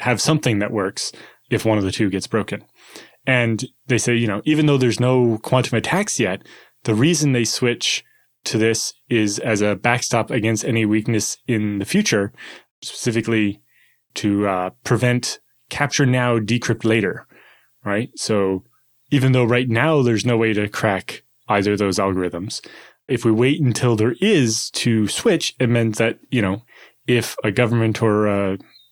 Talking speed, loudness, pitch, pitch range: 165 wpm, -19 LUFS, 115 Hz, 105-125 Hz